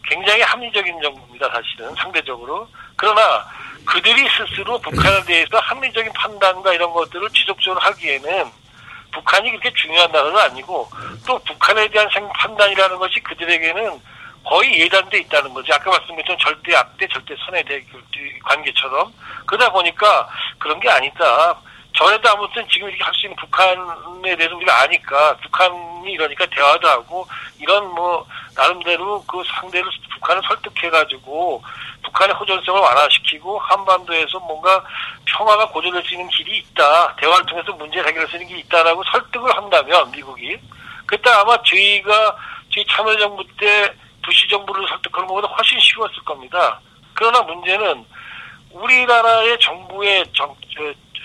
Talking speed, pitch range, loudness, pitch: 350 characters per minute, 175-210 Hz, -15 LUFS, 190 Hz